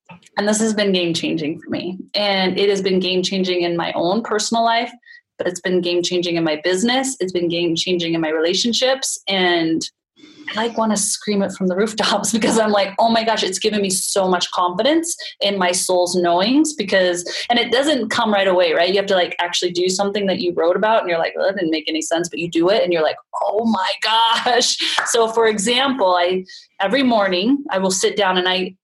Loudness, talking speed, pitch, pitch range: -18 LUFS, 230 wpm, 195 Hz, 180-230 Hz